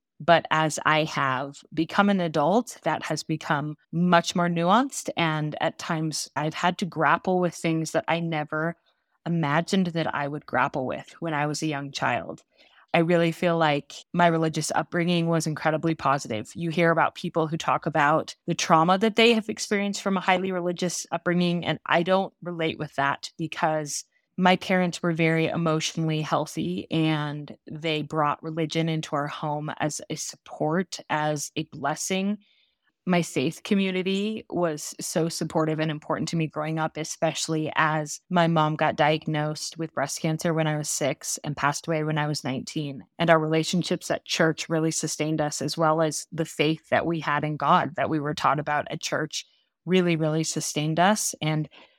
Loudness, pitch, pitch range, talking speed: -25 LUFS, 160 Hz, 155-175 Hz, 175 wpm